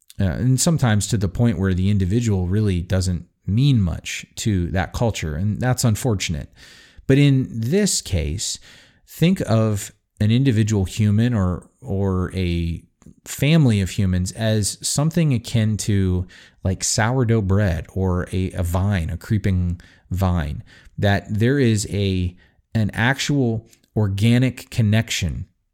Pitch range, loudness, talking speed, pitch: 90-115 Hz, -21 LUFS, 130 wpm, 105 Hz